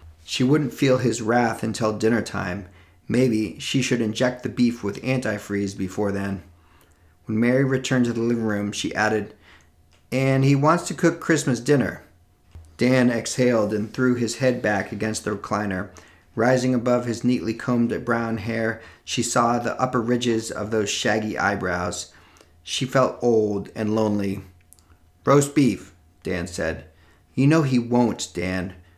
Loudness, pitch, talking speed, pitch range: -23 LUFS, 110 Hz, 155 wpm, 90-125 Hz